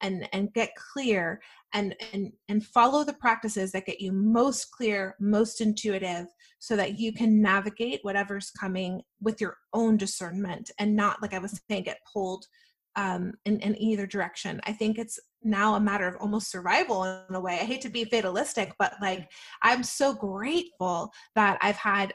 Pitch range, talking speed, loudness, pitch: 195-225 Hz, 180 wpm, -28 LUFS, 210 Hz